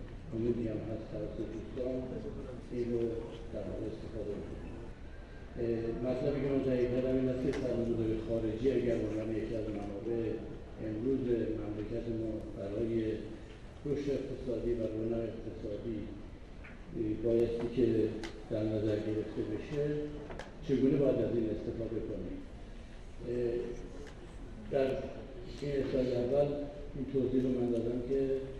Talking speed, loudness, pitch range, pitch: 110 wpm, -35 LUFS, 110-130 Hz, 115 Hz